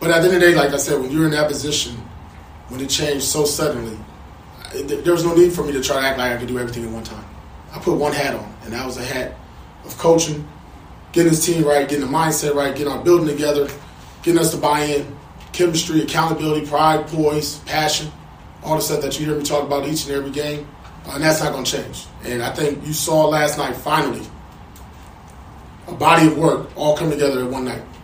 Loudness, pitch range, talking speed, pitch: -18 LUFS, 130-155 Hz, 235 wpm, 145 Hz